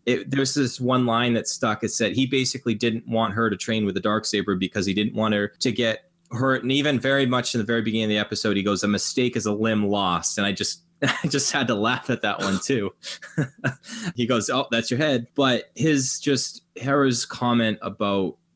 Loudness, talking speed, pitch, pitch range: -23 LUFS, 225 wpm, 120 Hz, 105-135 Hz